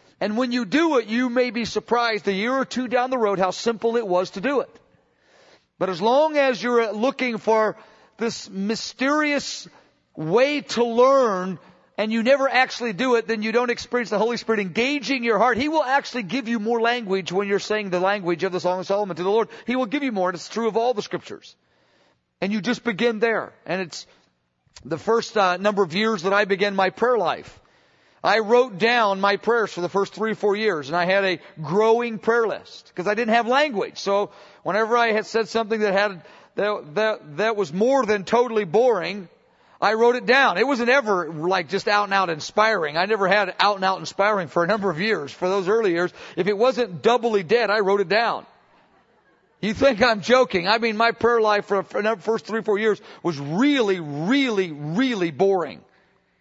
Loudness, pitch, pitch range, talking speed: -21 LUFS, 215 Hz, 195-240 Hz, 215 wpm